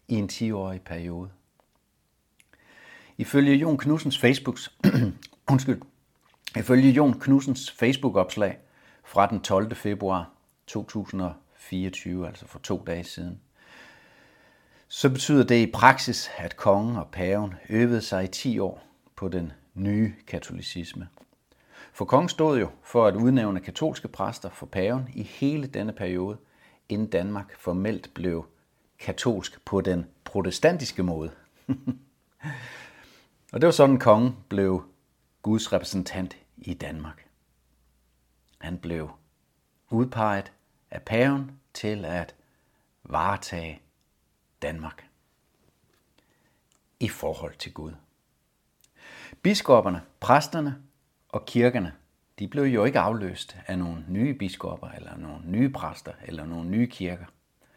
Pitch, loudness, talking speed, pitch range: 100 Hz, -26 LUFS, 110 wpm, 85-125 Hz